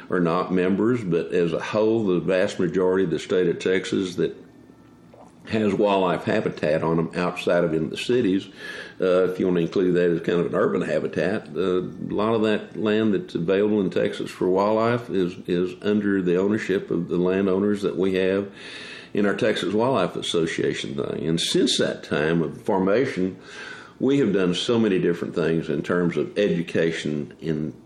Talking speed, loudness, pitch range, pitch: 185 wpm, -23 LUFS, 85-100 Hz, 90 Hz